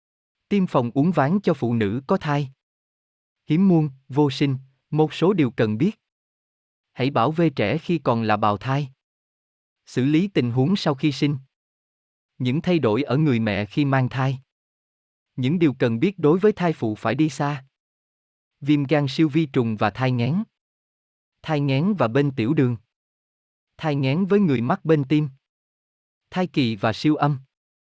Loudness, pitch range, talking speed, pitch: -22 LUFS, 125-155 Hz, 170 wpm, 140 Hz